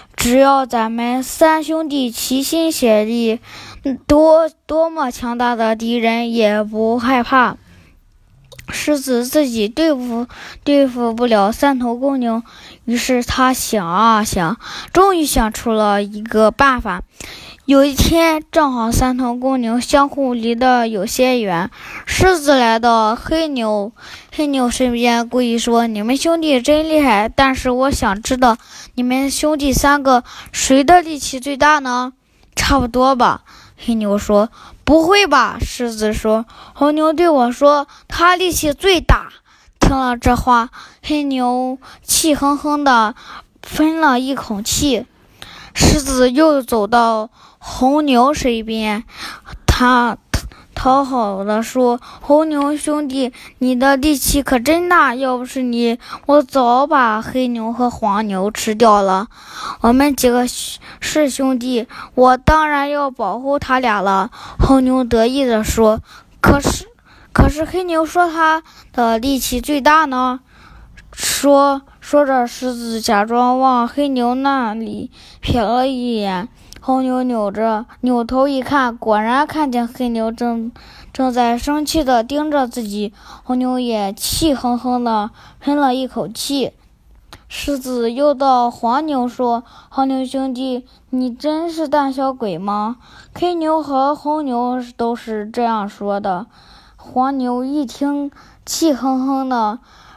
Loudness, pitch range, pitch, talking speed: -16 LUFS, 235-285 Hz, 255 Hz, 185 characters per minute